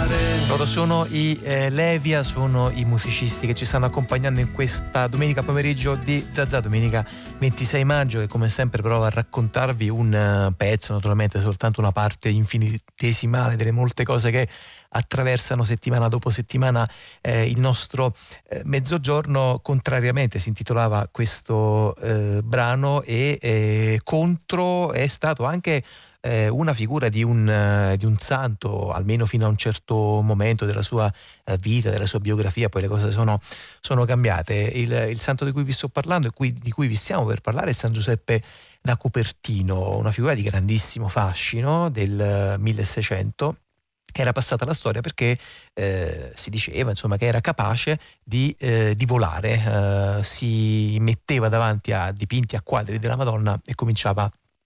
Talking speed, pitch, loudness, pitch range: 155 wpm, 115 Hz, -22 LUFS, 105-130 Hz